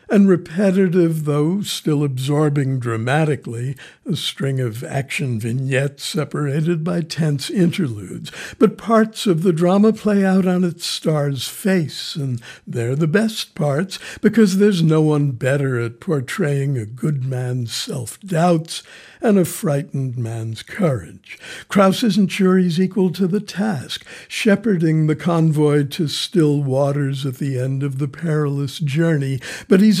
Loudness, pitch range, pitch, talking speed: -19 LUFS, 140-185 Hz, 155 Hz, 140 wpm